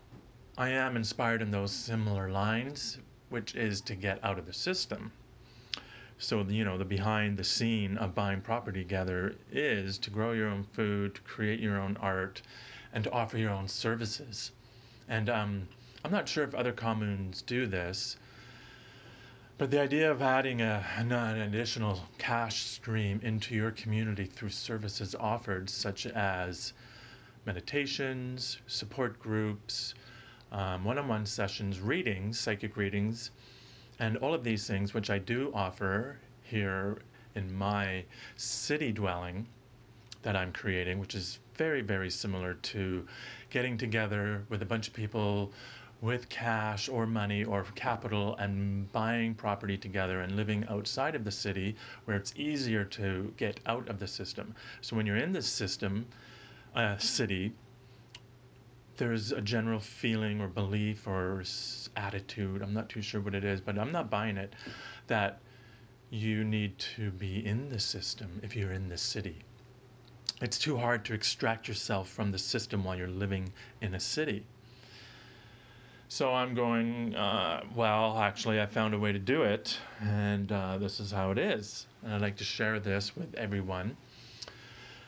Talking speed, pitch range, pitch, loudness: 155 wpm, 100-120 Hz, 110 Hz, -34 LUFS